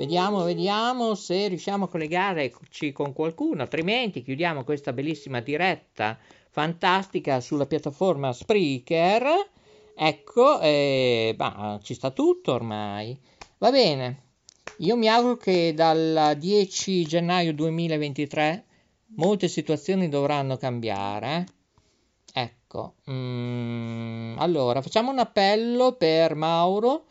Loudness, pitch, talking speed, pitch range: -24 LUFS, 160 Hz, 100 wpm, 135-190 Hz